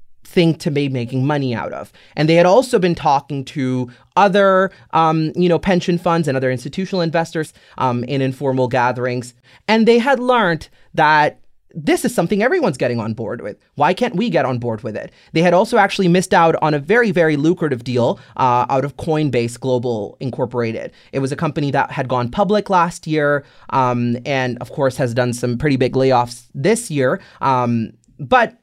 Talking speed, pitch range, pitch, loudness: 190 wpm, 125-170 Hz, 140 Hz, -17 LUFS